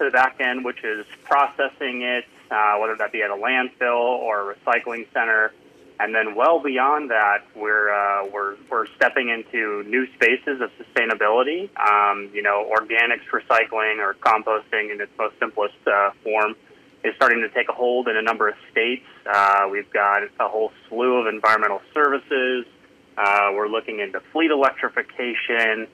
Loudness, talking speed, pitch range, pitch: -21 LUFS, 170 wpm, 105-125 Hz, 110 Hz